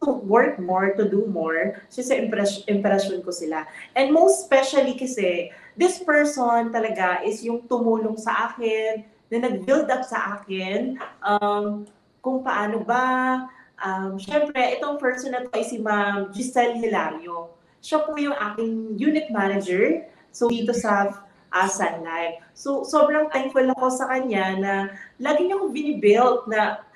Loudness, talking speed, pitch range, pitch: -23 LUFS, 150 wpm, 200-260 Hz, 225 Hz